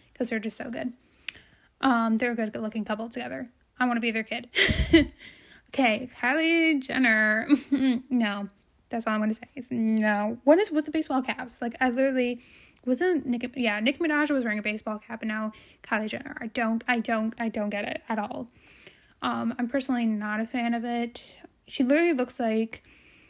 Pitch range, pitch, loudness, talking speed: 220-260 Hz, 240 Hz, -27 LUFS, 190 wpm